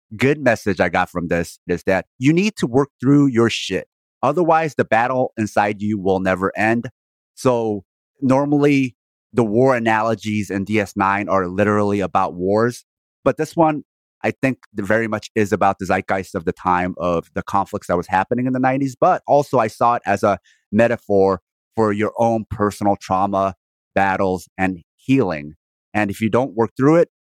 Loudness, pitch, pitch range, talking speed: -19 LUFS, 105 Hz, 95-125 Hz, 175 wpm